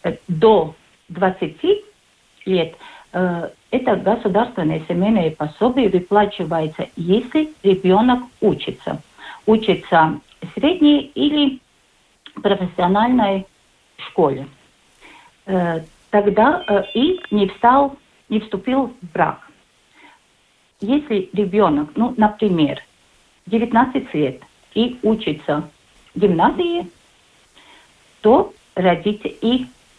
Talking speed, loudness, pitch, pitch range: 75 wpm, -18 LUFS, 210 Hz, 180-245 Hz